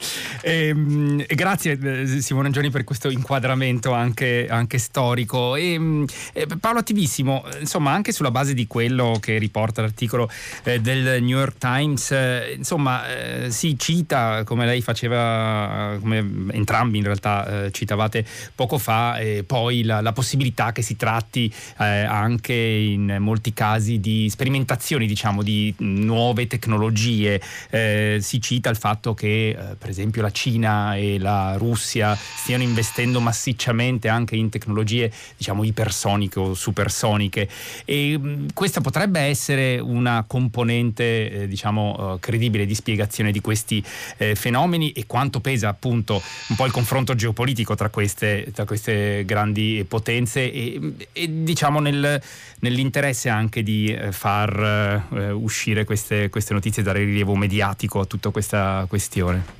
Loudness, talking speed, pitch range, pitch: -22 LUFS, 140 wpm, 105-130 Hz, 115 Hz